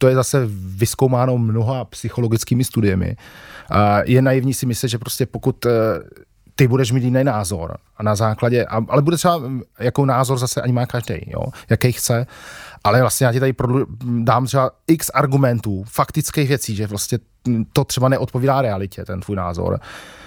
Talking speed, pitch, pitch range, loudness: 155 wpm, 125 Hz, 110-130 Hz, -19 LUFS